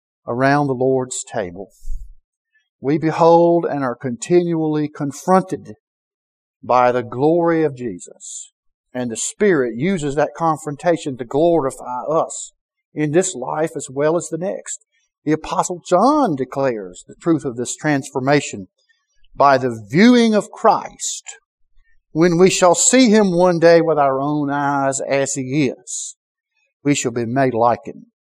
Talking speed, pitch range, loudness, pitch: 140 wpm, 135-185 Hz, -17 LUFS, 155 Hz